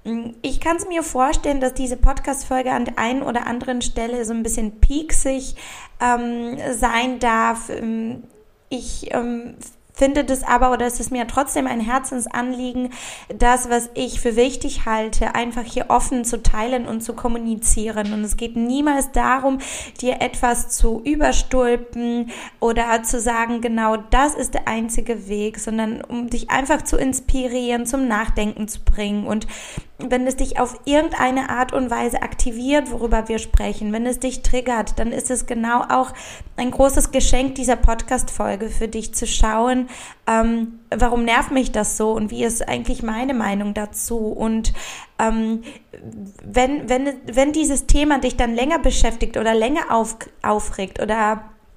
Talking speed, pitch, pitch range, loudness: 160 wpm, 240 Hz, 225-255 Hz, -21 LUFS